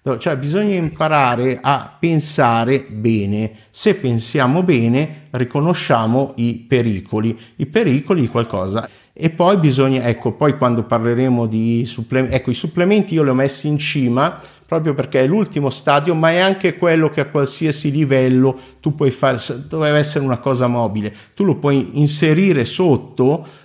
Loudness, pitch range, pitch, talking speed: -17 LUFS, 120-155 Hz, 135 Hz, 150 wpm